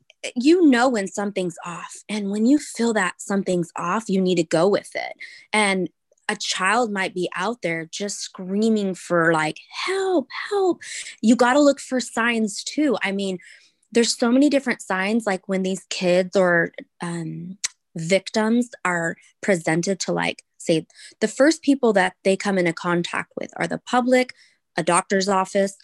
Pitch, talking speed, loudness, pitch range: 195 Hz, 165 wpm, -22 LUFS, 180-235 Hz